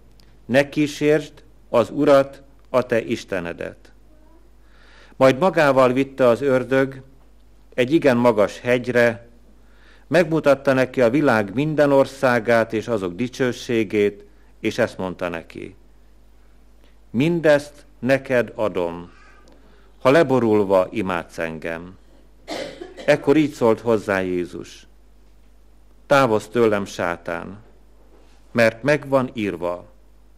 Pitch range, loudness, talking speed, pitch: 100-135 Hz, -20 LUFS, 95 wpm, 120 Hz